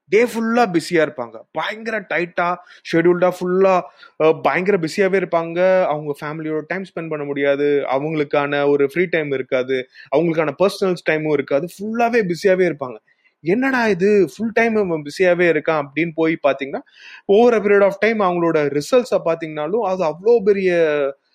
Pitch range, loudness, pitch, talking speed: 150-200 Hz, -18 LUFS, 175 Hz, 135 wpm